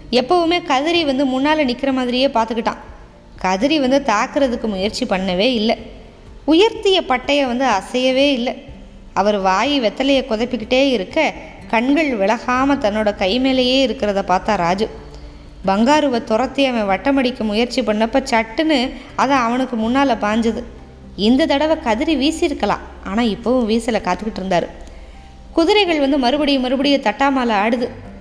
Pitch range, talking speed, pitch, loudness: 215-275 Hz, 120 wpm, 250 Hz, -17 LUFS